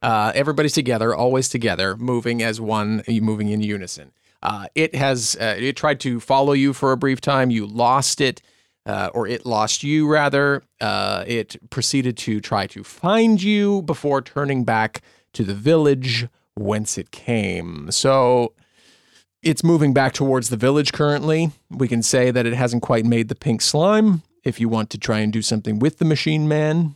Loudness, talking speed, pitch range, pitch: -20 LUFS, 180 wpm, 110-145 Hz, 125 Hz